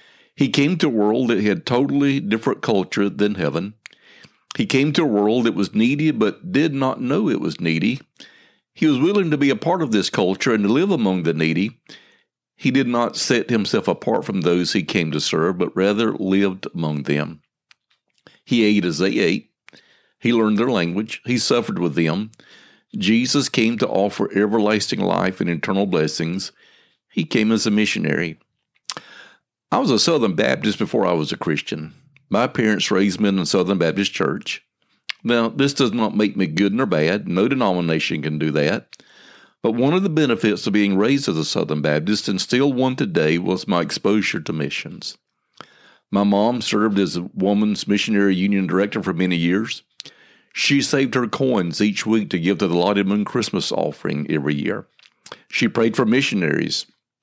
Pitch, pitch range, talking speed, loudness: 105 Hz, 95-125 Hz, 180 wpm, -20 LUFS